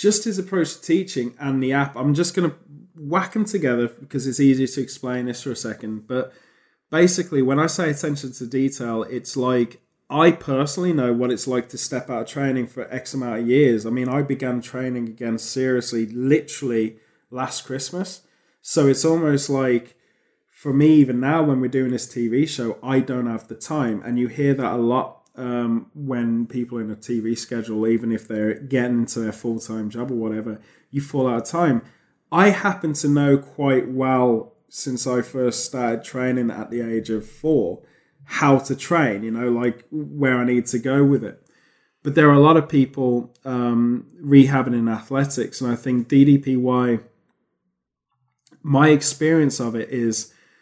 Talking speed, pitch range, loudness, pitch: 185 wpm, 120-145 Hz, -21 LUFS, 130 Hz